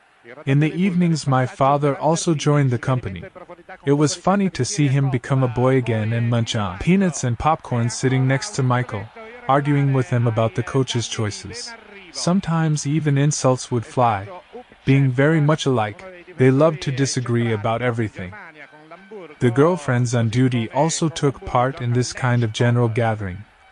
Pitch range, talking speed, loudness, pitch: 120-155 Hz, 160 wpm, -20 LUFS, 135 Hz